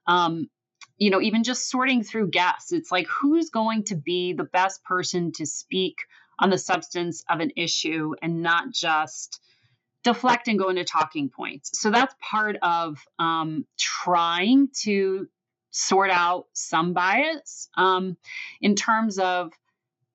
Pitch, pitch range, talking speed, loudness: 185 Hz, 170-220 Hz, 145 wpm, -24 LUFS